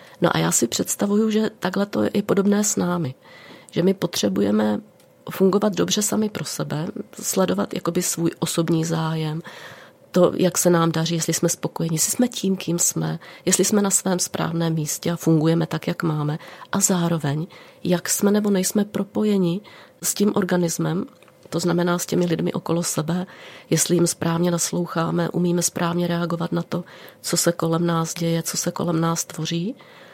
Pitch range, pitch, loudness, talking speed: 165-190 Hz, 175 Hz, -22 LUFS, 170 wpm